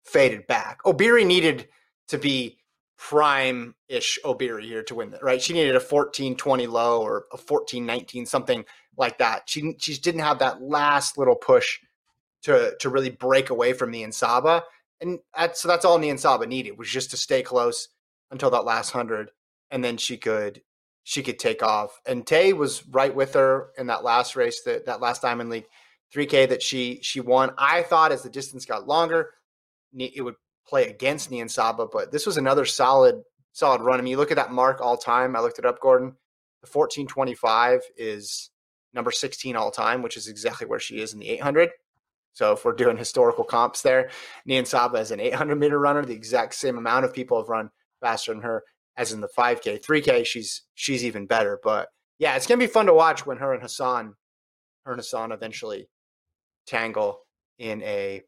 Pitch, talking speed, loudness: 145 Hz, 200 wpm, -23 LUFS